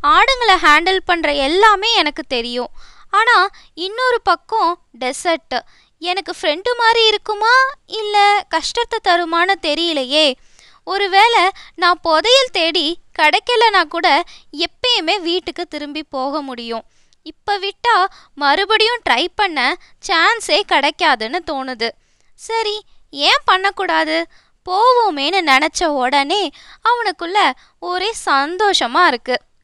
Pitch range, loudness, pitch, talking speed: 305-410 Hz, -15 LUFS, 360 Hz, 95 wpm